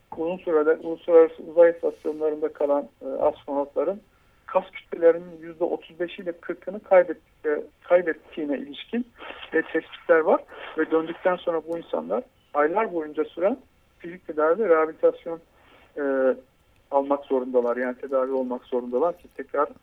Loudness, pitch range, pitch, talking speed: -25 LUFS, 145-185 Hz, 165 Hz, 125 wpm